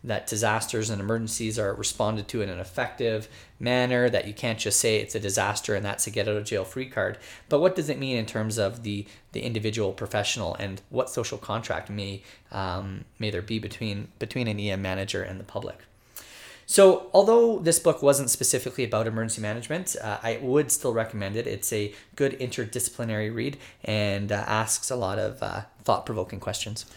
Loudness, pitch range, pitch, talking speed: -26 LUFS, 105-125 Hz, 110 Hz, 195 wpm